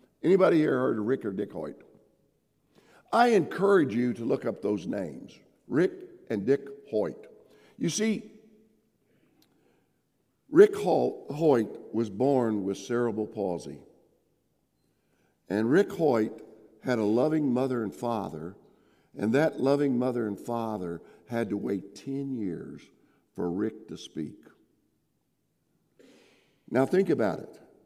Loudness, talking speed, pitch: -28 LUFS, 125 wpm, 130 Hz